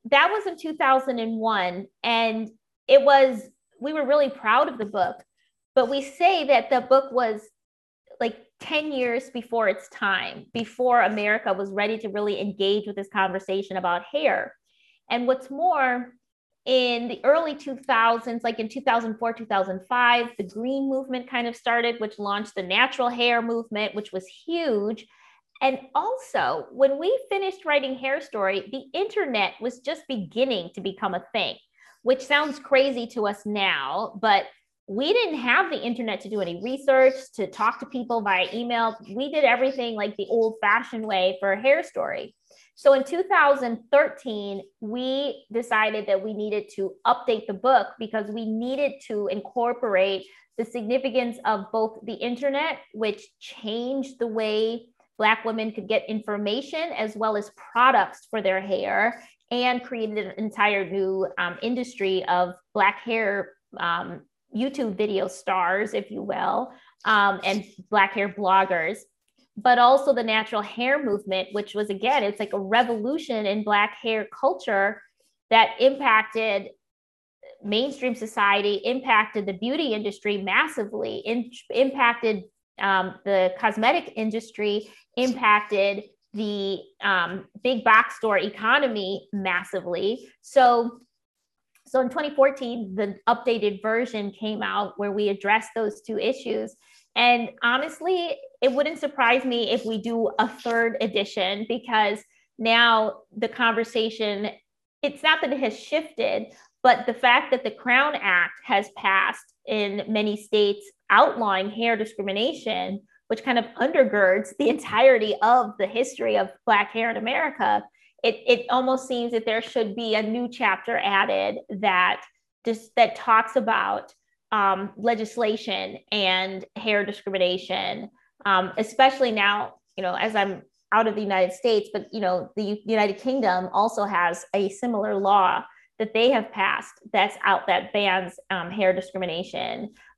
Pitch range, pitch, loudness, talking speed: 205-255 Hz, 225 Hz, -24 LUFS, 145 wpm